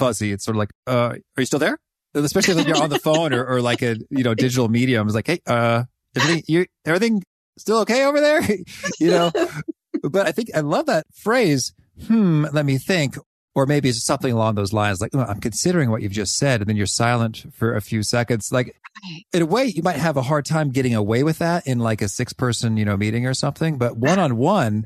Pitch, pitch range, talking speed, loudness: 130 Hz, 115-160 Hz, 240 wpm, -20 LUFS